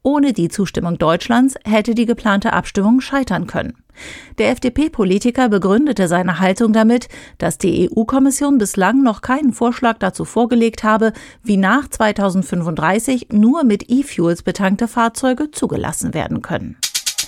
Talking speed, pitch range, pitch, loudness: 130 wpm, 190-250 Hz, 225 Hz, -16 LUFS